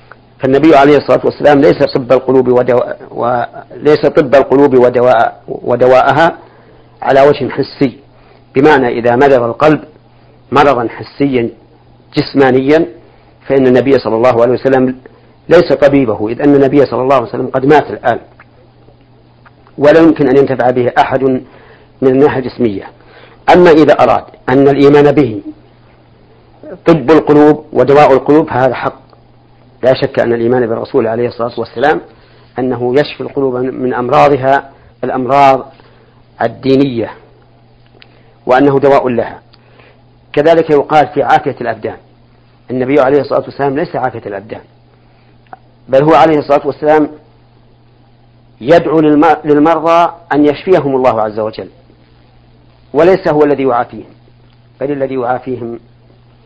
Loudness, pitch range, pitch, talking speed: -10 LUFS, 120-145 Hz, 130 Hz, 120 wpm